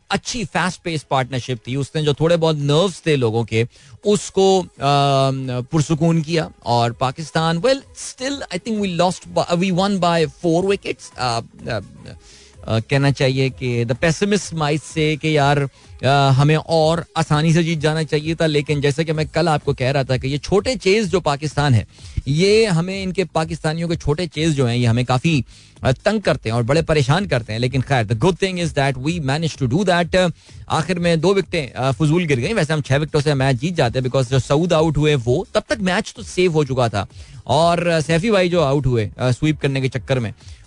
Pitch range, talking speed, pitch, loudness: 135-170 Hz, 200 wpm, 155 Hz, -19 LUFS